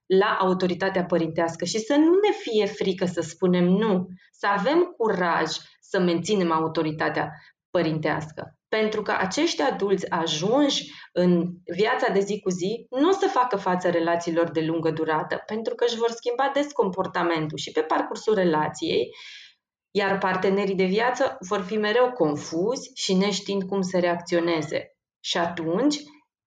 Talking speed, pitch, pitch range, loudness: 145 wpm, 195 Hz, 170-230 Hz, -24 LUFS